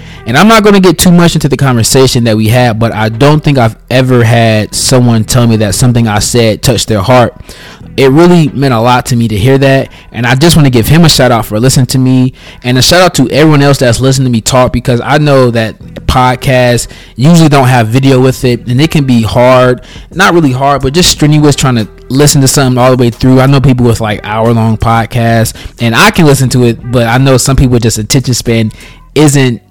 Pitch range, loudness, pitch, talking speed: 115-135 Hz, -6 LUFS, 125 Hz, 245 wpm